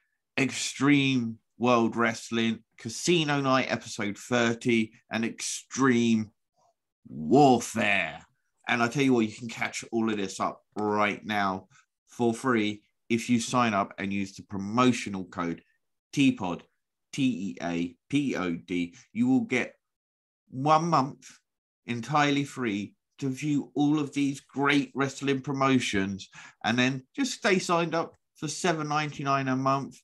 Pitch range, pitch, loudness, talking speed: 110-140 Hz, 125 Hz, -27 LUFS, 135 wpm